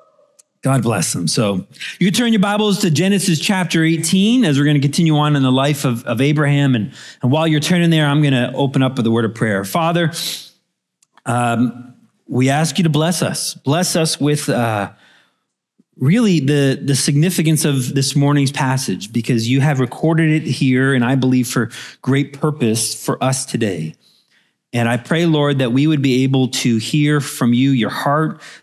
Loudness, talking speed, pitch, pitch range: -16 LUFS, 190 wpm, 140 Hz, 130-160 Hz